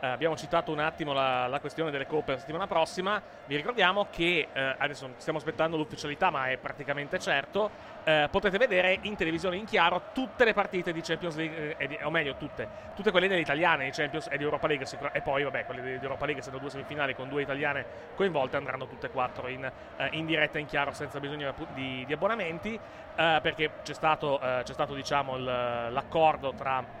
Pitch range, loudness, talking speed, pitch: 140-165 Hz, -30 LUFS, 215 wpm, 150 Hz